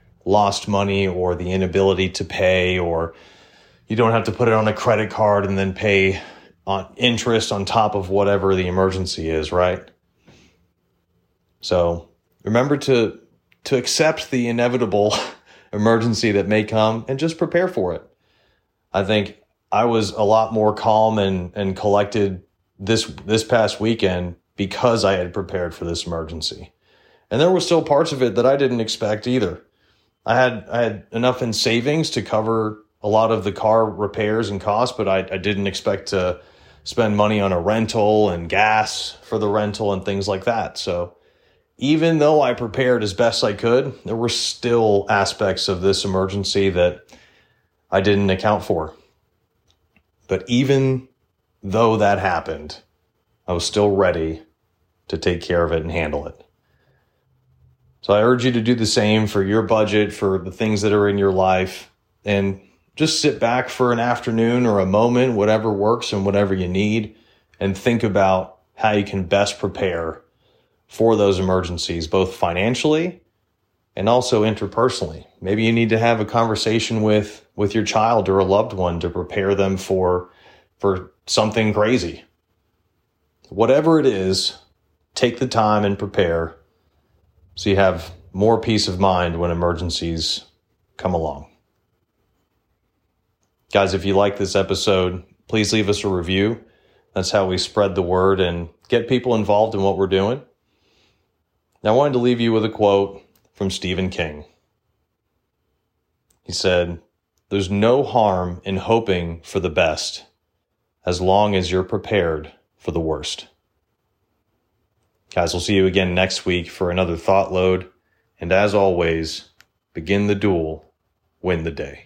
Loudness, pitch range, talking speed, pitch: -19 LUFS, 95-110 Hz, 160 wpm, 100 Hz